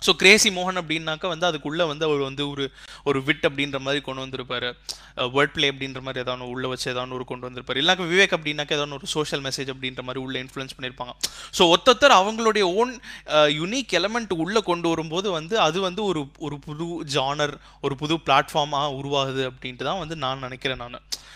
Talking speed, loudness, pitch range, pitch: 185 wpm, -23 LUFS, 135-175 Hz, 145 Hz